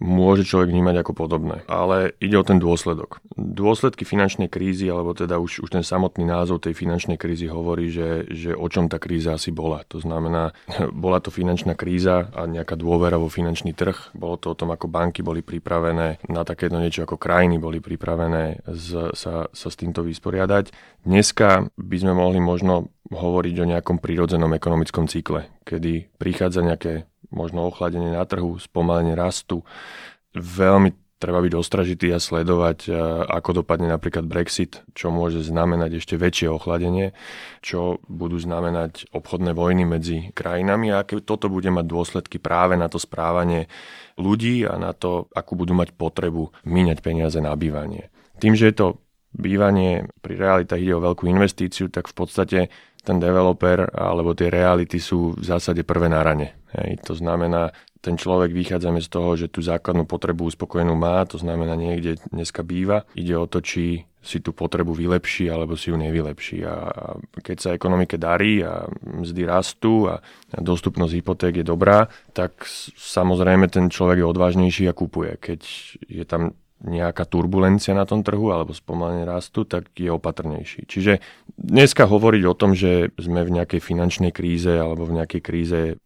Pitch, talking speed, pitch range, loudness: 85 Hz, 165 wpm, 85-90 Hz, -21 LUFS